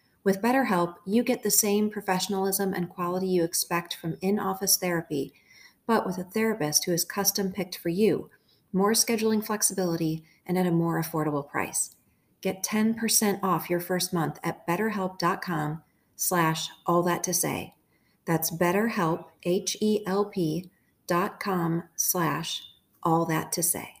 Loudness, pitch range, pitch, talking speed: -27 LUFS, 170-200 Hz, 180 Hz, 135 wpm